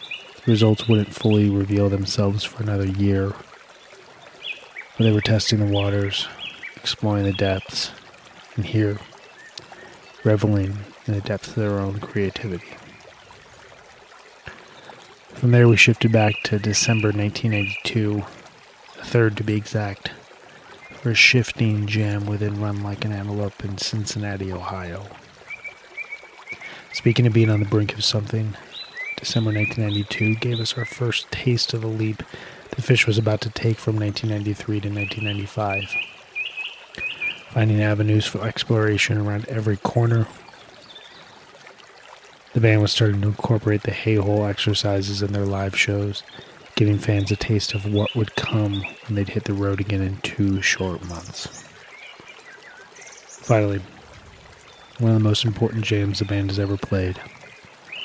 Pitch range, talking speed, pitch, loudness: 100-110 Hz, 135 wpm, 105 Hz, -22 LUFS